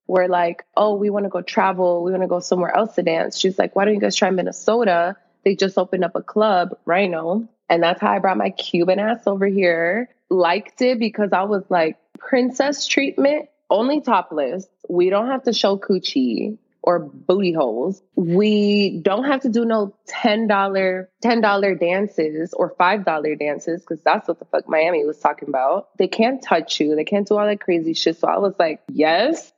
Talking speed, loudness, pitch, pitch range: 205 wpm, -19 LUFS, 195 Hz, 175-220 Hz